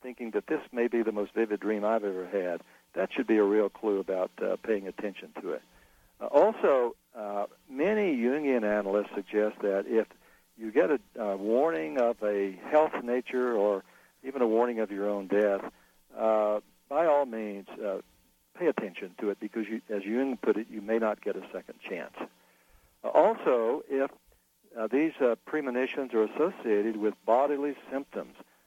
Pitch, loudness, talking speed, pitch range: 110 Hz, -29 LUFS, 175 wpm, 105-130 Hz